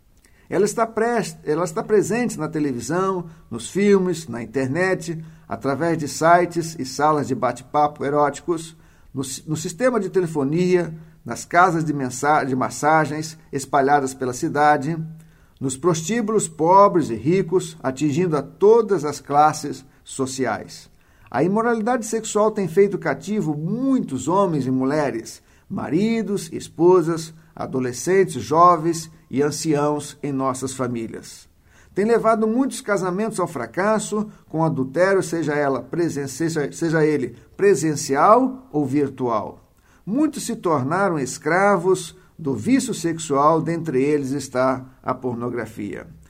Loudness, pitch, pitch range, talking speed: -21 LUFS, 160 Hz, 135-190 Hz, 120 wpm